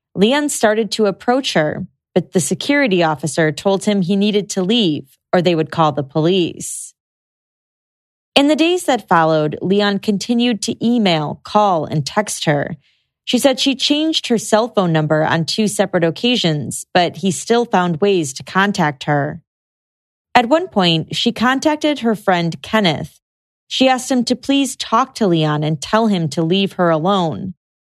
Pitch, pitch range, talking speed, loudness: 195 Hz, 165-235 Hz, 165 wpm, -16 LUFS